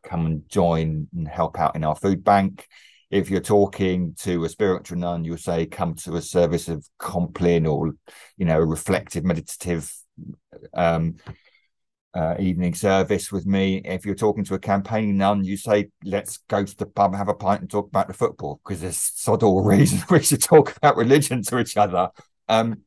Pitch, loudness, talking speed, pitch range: 95 Hz, -22 LUFS, 190 wpm, 85-100 Hz